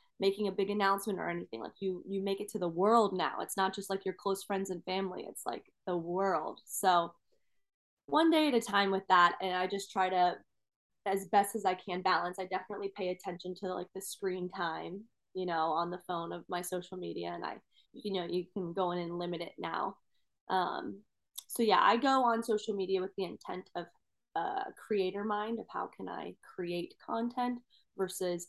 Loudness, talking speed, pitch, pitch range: -34 LUFS, 210 wpm, 190 Hz, 180-200 Hz